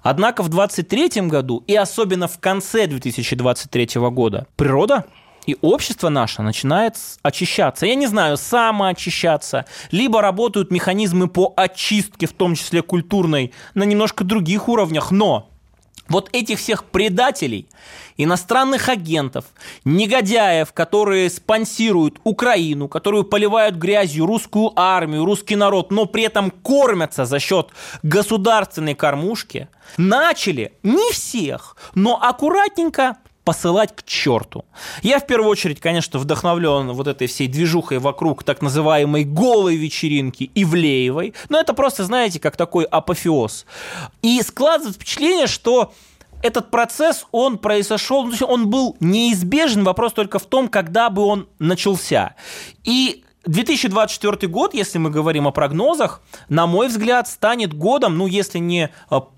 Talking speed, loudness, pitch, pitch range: 125 wpm, -18 LUFS, 195 Hz, 160-225 Hz